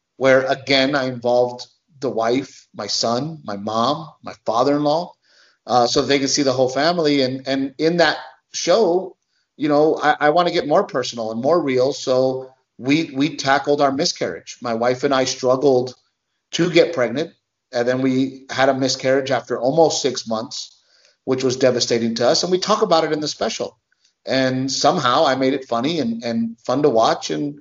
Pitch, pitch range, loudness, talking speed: 130 Hz, 125-145 Hz, -19 LUFS, 185 wpm